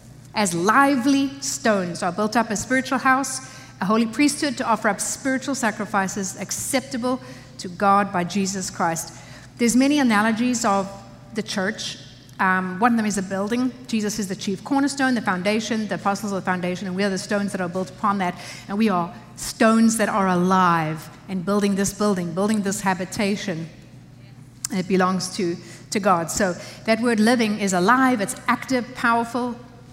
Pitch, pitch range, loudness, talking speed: 200 Hz, 185-230 Hz, -22 LUFS, 175 wpm